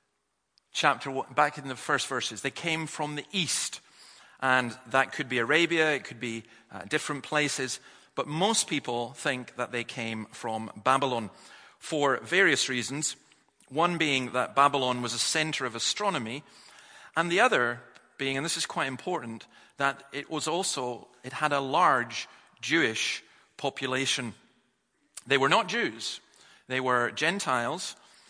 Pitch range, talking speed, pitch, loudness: 120-150 Hz, 145 wpm, 135 Hz, -28 LUFS